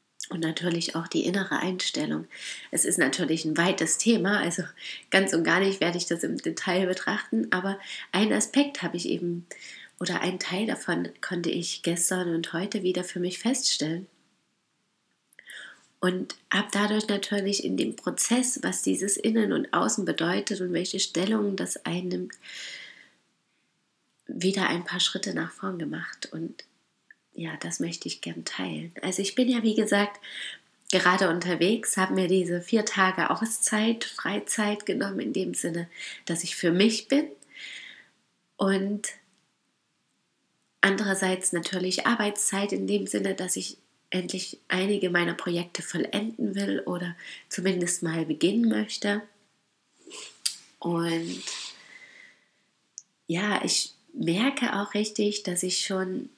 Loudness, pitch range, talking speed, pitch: -27 LUFS, 175-205 Hz, 135 wpm, 190 Hz